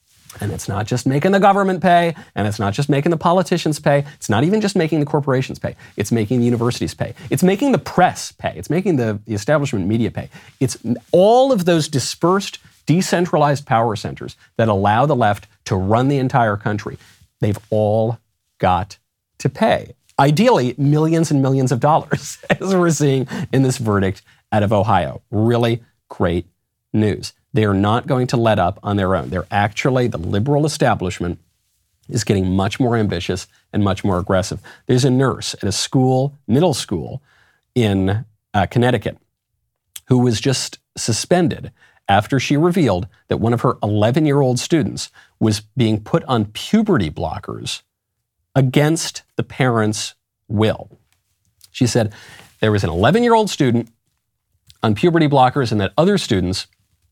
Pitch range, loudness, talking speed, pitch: 105-145 Hz, -18 LUFS, 165 wpm, 120 Hz